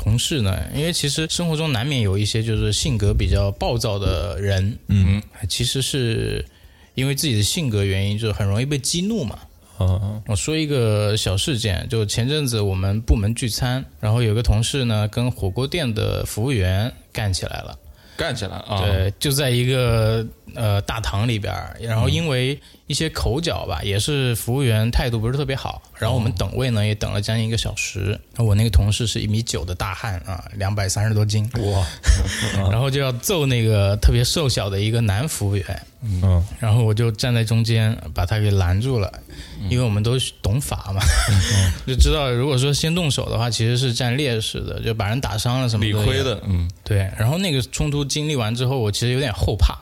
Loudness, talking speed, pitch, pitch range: -21 LUFS, 295 characters per minute, 110 Hz, 100-125 Hz